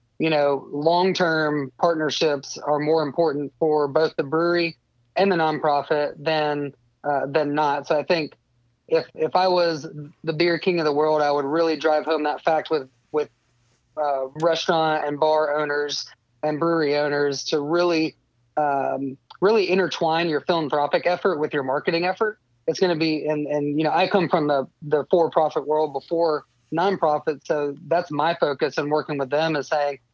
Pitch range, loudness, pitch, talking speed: 145-165 Hz, -22 LUFS, 155 Hz, 175 wpm